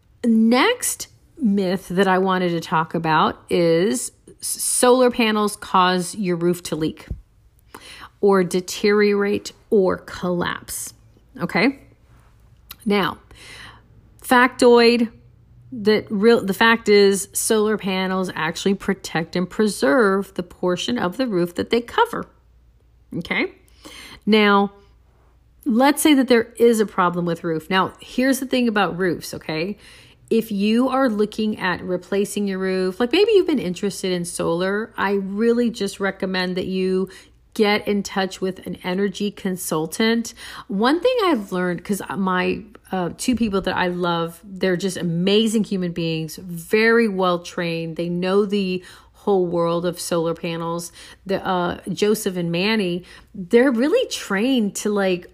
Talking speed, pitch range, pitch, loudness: 135 wpm, 180-225 Hz, 195 Hz, -20 LUFS